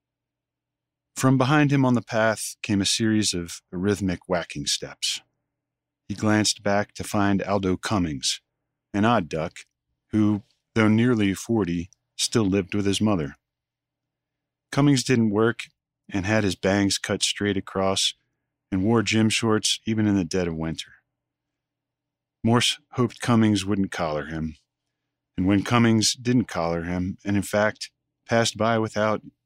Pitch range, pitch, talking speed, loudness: 95-115 Hz, 105 Hz, 145 wpm, -23 LUFS